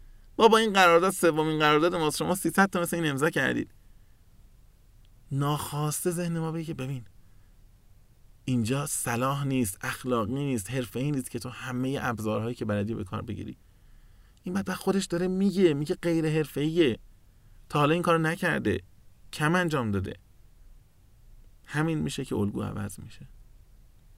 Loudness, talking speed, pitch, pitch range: -27 LUFS, 145 wpm, 130 Hz, 105-160 Hz